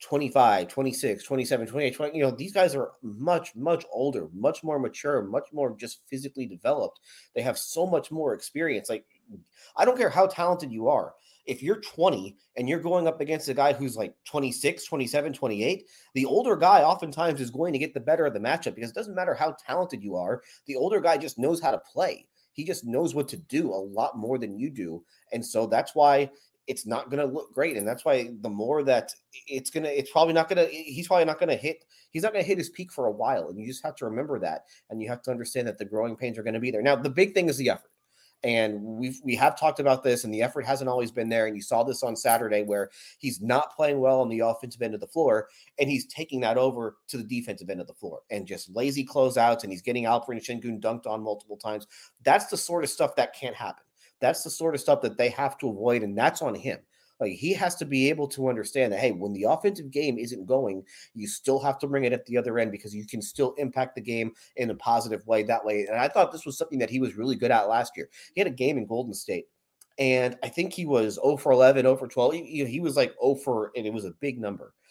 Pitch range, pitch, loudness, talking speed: 115-150 Hz, 130 Hz, -27 LUFS, 255 wpm